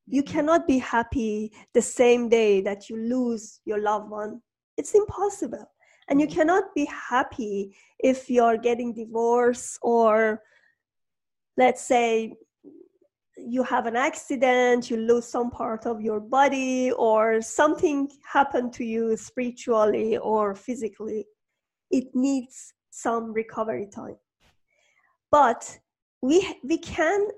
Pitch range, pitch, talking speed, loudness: 225-275 Hz, 245 Hz, 120 wpm, -24 LUFS